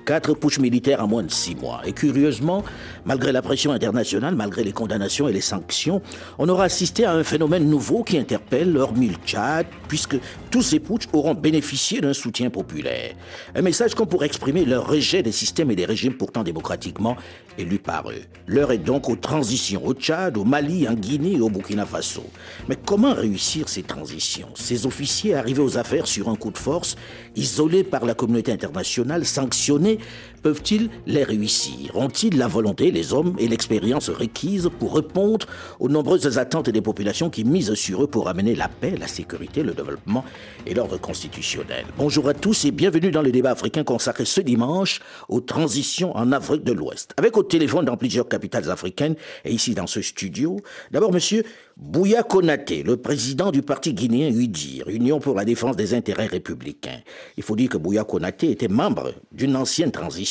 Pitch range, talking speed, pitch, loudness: 115-165 Hz, 185 wpm, 140 Hz, -22 LUFS